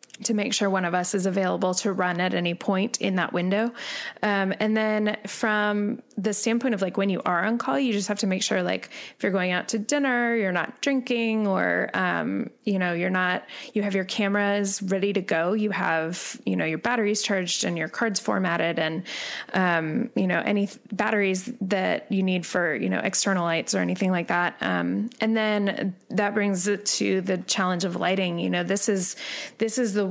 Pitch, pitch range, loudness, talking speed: 200 Hz, 180-215 Hz, -25 LUFS, 210 wpm